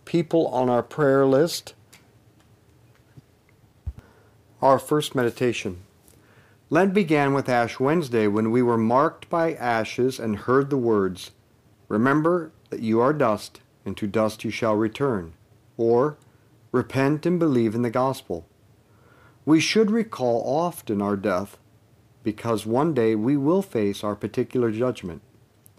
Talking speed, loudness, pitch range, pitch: 130 wpm, -23 LUFS, 110-135 Hz, 115 Hz